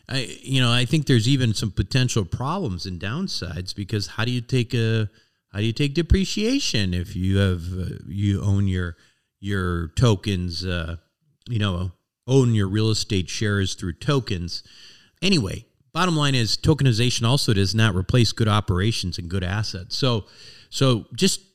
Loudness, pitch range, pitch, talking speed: -23 LUFS, 95-130 Hz, 110 Hz, 165 wpm